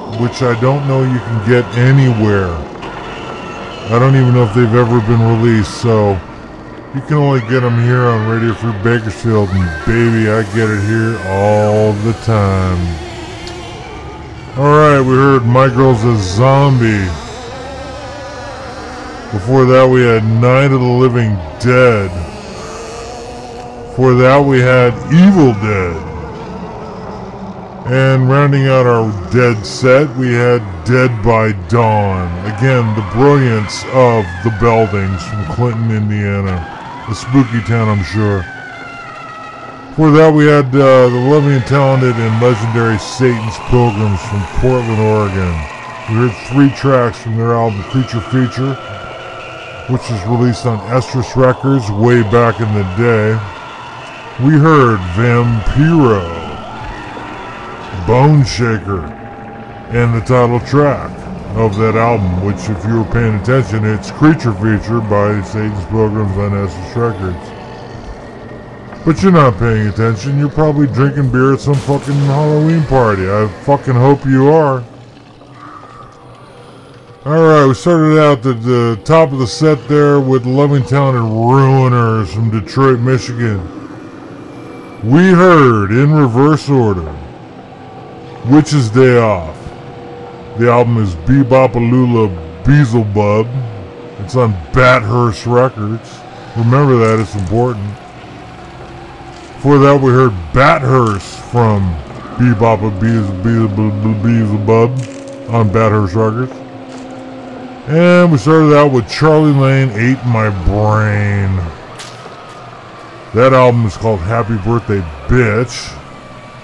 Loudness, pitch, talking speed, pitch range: -11 LUFS, 120 Hz, 120 wpm, 110-130 Hz